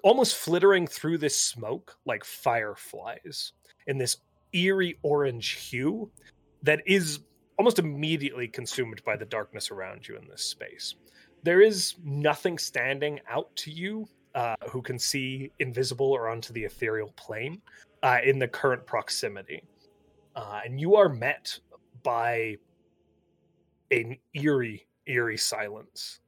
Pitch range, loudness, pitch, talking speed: 120-160 Hz, -28 LUFS, 135 Hz, 130 wpm